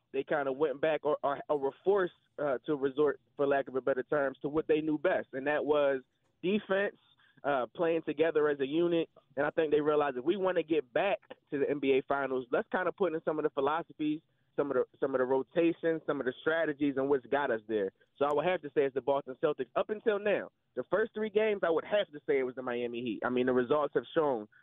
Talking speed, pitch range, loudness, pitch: 260 wpm, 135-165 Hz, -32 LUFS, 150 Hz